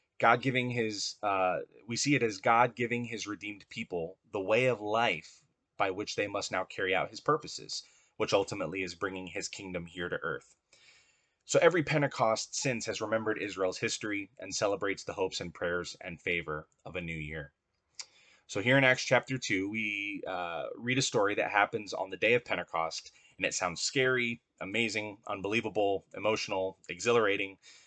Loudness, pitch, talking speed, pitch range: -32 LUFS, 105 Hz, 175 wpm, 95-120 Hz